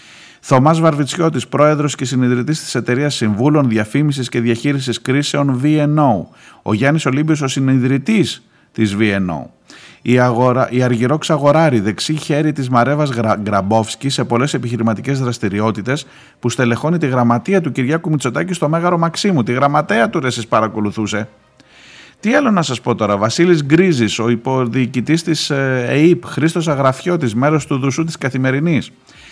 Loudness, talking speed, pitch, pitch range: -15 LUFS, 140 wpm, 135 Hz, 120-150 Hz